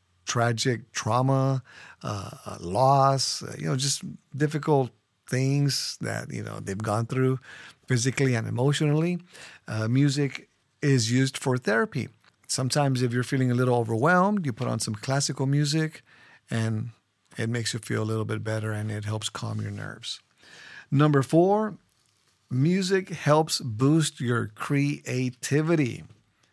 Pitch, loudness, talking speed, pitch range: 130 Hz, -26 LUFS, 135 wpm, 115-145 Hz